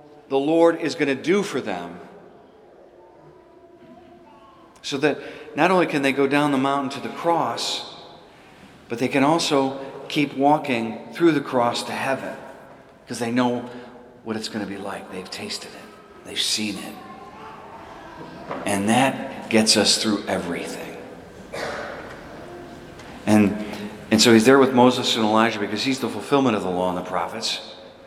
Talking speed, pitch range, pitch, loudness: 155 wpm, 105-140 Hz, 120 Hz, -21 LUFS